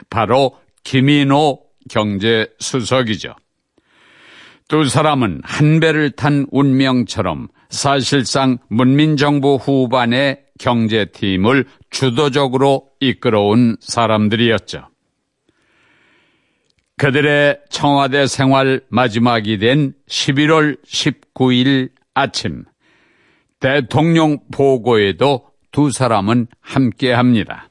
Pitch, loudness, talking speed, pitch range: 130 Hz, -15 LUFS, 185 characters per minute, 120-145 Hz